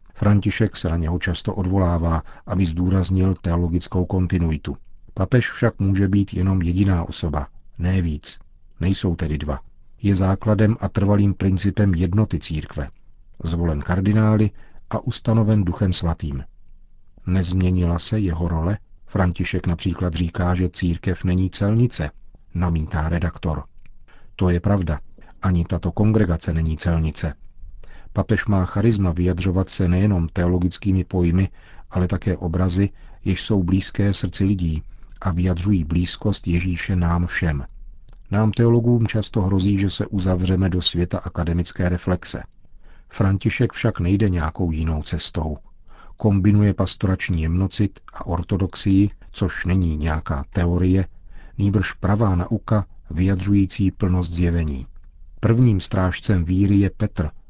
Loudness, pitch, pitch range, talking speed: -21 LUFS, 90 Hz, 85-100 Hz, 120 wpm